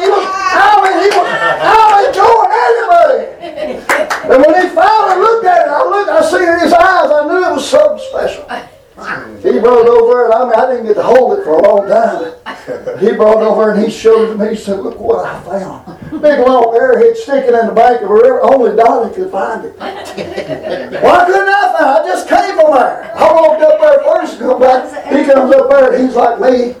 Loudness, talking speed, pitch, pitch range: -9 LUFS, 235 wpm, 315 Hz, 255-390 Hz